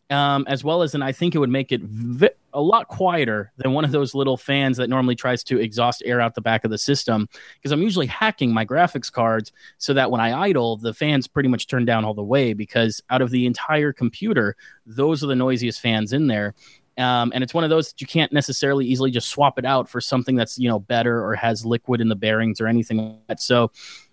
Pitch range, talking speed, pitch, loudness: 115-140 Hz, 255 wpm, 125 Hz, -21 LUFS